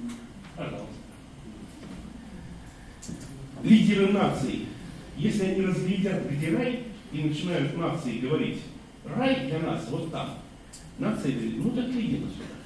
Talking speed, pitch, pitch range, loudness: 100 wpm, 190 Hz, 160-230 Hz, -28 LUFS